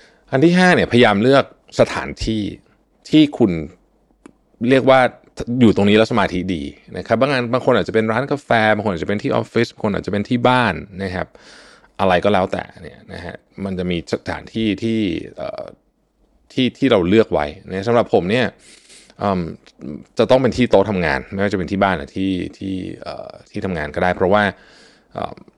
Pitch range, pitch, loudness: 95-125 Hz, 110 Hz, -17 LUFS